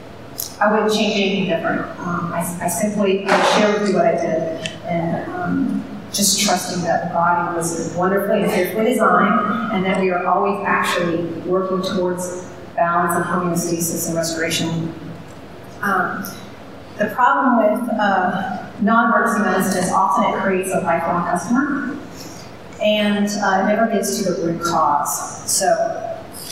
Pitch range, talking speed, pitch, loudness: 170-210 Hz, 145 wpm, 185 Hz, -18 LUFS